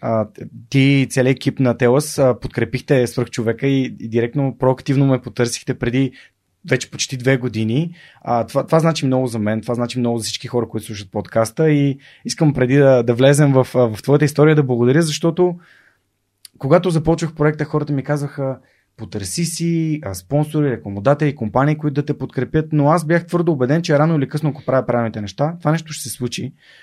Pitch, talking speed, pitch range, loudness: 135 Hz, 190 wpm, 120-150 Hz, -18 LUFS